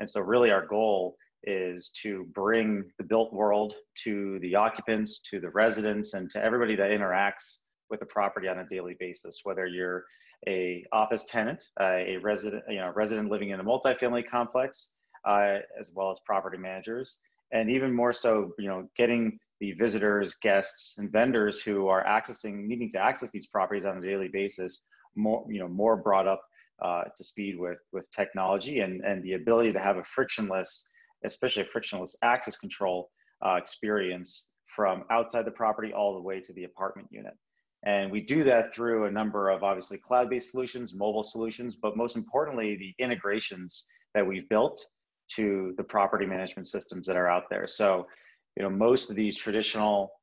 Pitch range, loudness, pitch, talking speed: 95-115 Hz, -29 LUFS, 105 Hz, 180 wpm